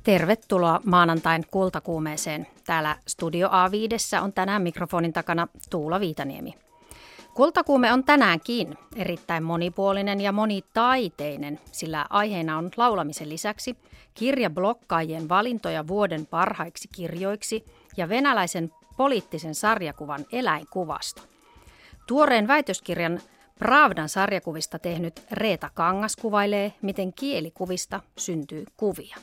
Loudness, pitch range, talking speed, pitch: -25 LUFS, 165-215 Hz, 95 wpm, 185 Hz